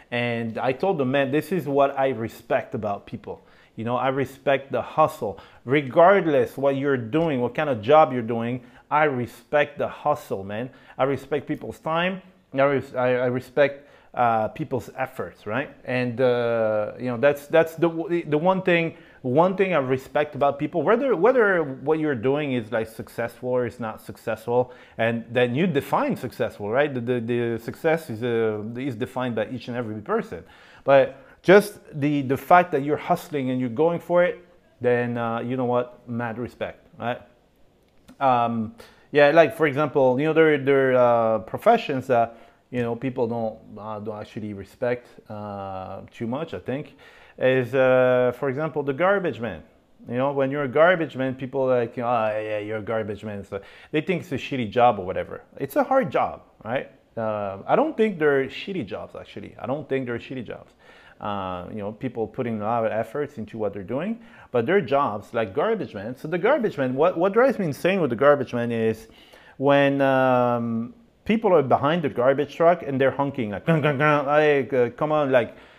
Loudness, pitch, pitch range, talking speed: -23 LUFS, 130 Hz, 115-150 Hz, 190 wpm